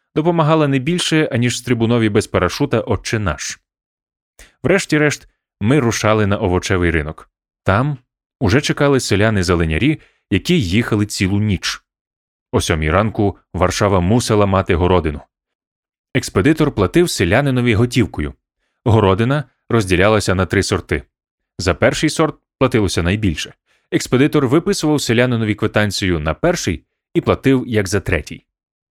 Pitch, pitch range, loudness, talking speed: 110 Hz, 95-130 Hz, -16 LUFS, 115 wpm